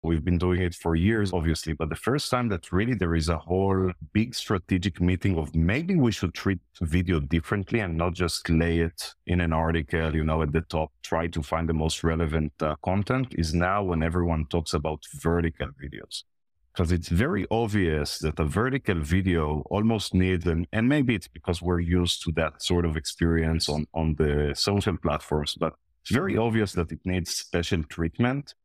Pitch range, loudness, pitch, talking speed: 80-95 Hz, -26 LUFS, 85 Hz, 195 wpm